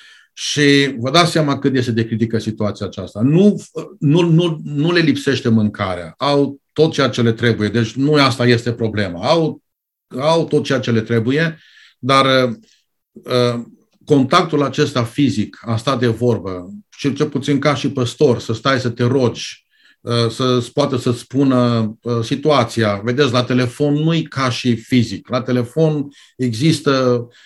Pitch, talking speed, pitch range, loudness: 130 Hz, 160 wpm, 120-145 Hz, -16 LUFS